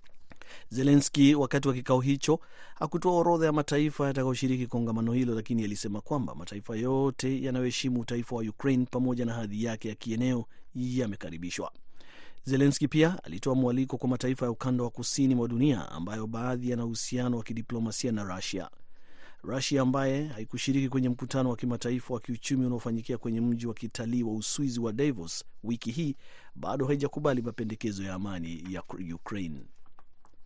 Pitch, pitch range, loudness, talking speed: 125 Hz, 115-135 Hz, -30 LUFS, 150 wpm